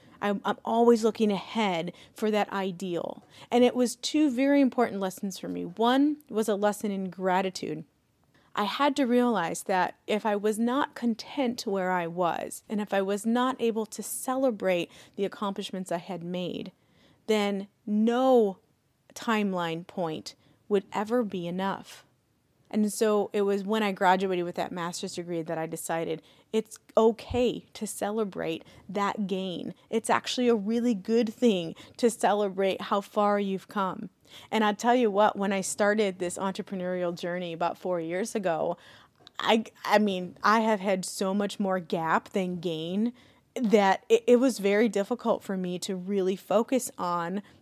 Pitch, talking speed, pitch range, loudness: 205 Hz, 160 wpm, 185-225 Hz, -28 LUFS